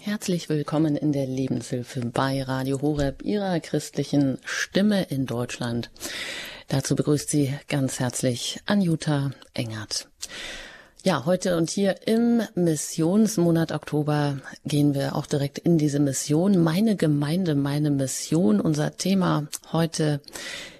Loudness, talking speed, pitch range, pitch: -25 LUFS, 120 wpm, 140-170 Hz, 150 Hz